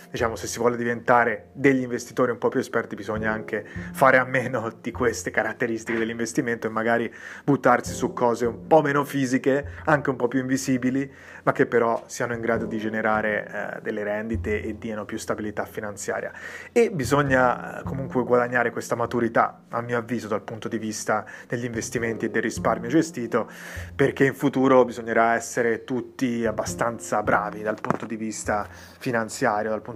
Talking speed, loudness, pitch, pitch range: 170 wpm, -24 LUFS, 115 Hz, 110-130 Hz